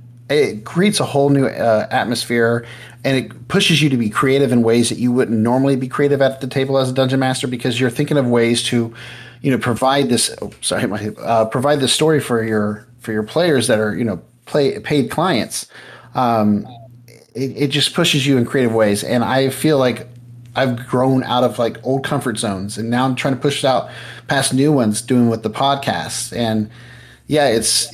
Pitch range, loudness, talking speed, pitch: 115-135 Hz, -17 LUFS, 205 wpm, 125 Hz